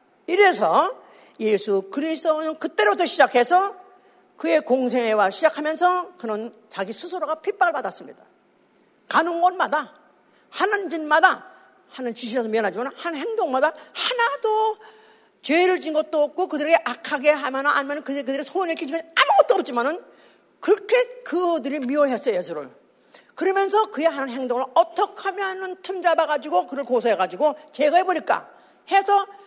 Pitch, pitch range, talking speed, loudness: 325 Hz, 285-375 Hz, 340 characters per minute, -22 LUFS